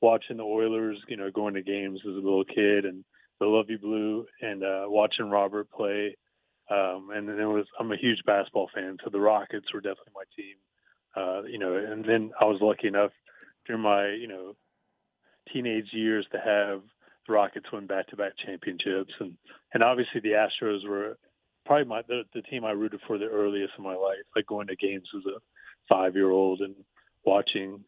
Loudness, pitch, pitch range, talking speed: -28 LUFS, 105 Hz, 100-110 Hz, 190 wpm